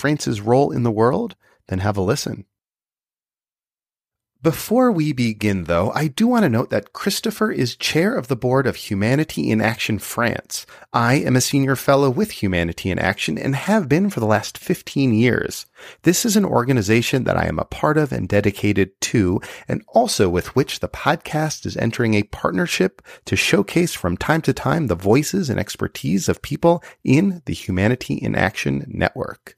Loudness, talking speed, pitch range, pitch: -20 LUFS, 180 wpm, 105-155 Hz, 125 Hz